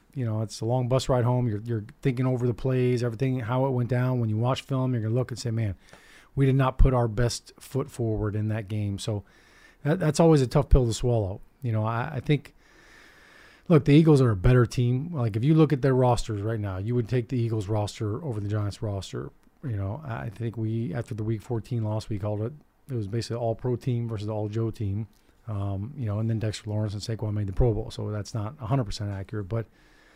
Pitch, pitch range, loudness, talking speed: 115 Hz, 110-125 Hz, -27 LUFS, 245 wpm